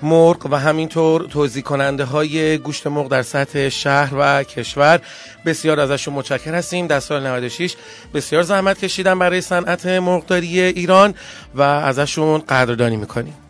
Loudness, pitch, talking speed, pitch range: -17 LUFS, 150 Hz, 140 wpm, 140-175 Hz